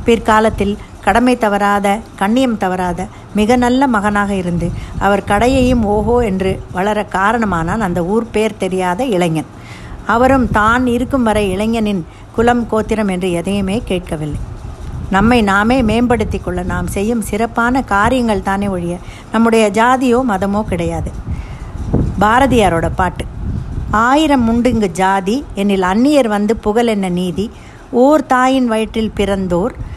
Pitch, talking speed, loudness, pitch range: 210 Hz, 120 wpm, -14 LUFS, 190-235 Hz